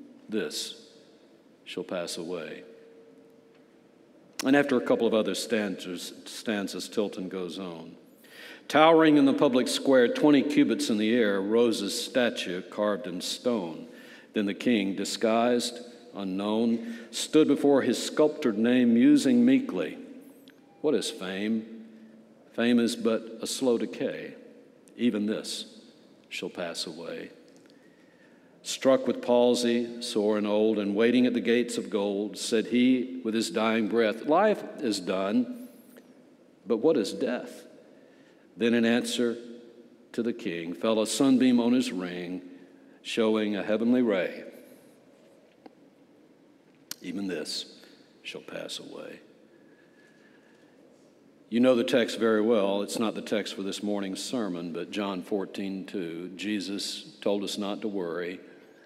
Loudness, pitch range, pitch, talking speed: -27 LUFS, 105-130 Hz, 115 Hz, 130 wpm